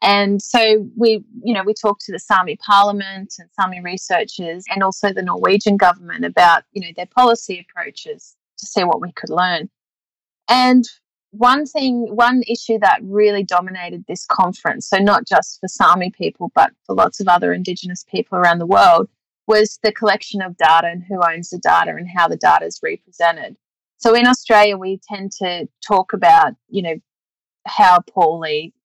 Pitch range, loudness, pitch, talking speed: 180-225 Hz, -16 LUFS, 200 Hz, 175 wpm